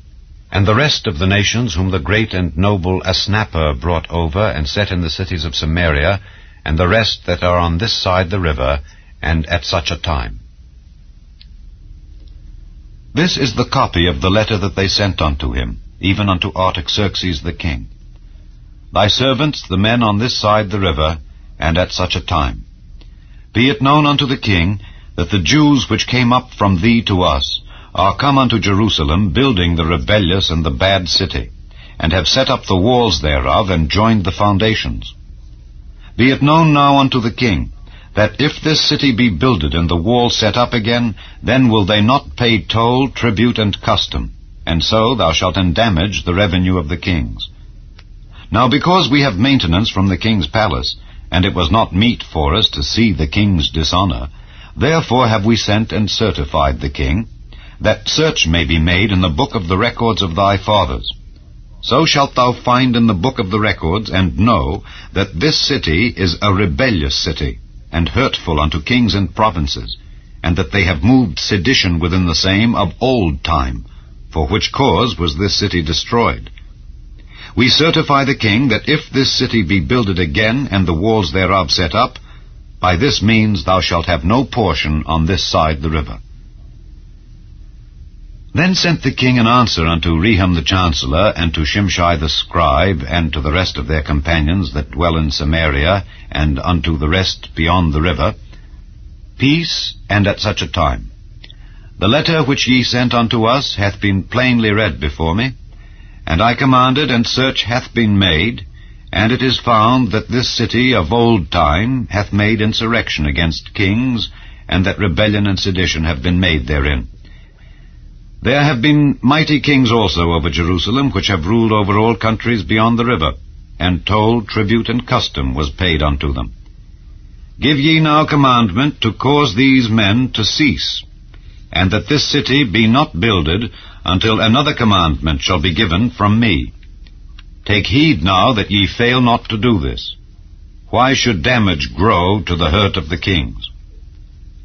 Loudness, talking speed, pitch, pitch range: -14 LUFS, 170 wpm, 95 Hz, 80-115 Hz